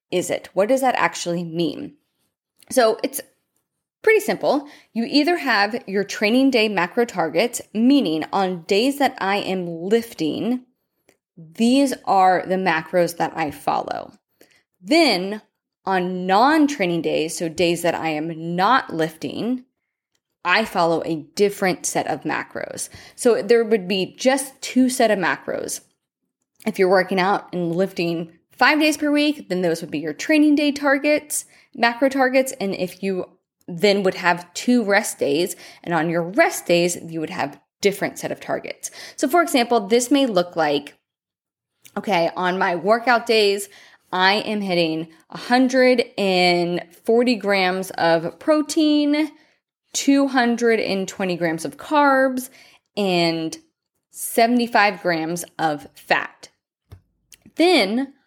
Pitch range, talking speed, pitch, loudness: 175-255 Hz, 135 wpm, 200 Hz, -20 LUFS